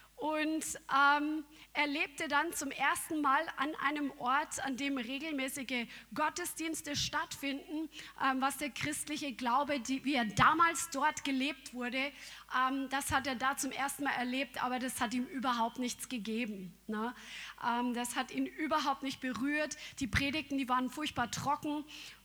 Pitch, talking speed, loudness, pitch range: 275 Hz, 155 wpm, -34 LUFS, 255-300 Hz